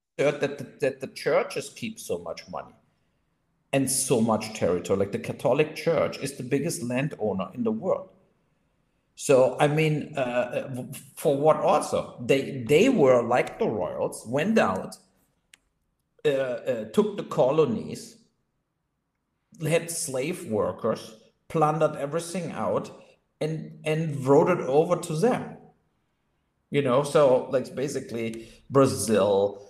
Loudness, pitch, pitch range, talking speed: -25 LUFS, 155 Hz, 135-170 Hz, 125 wpm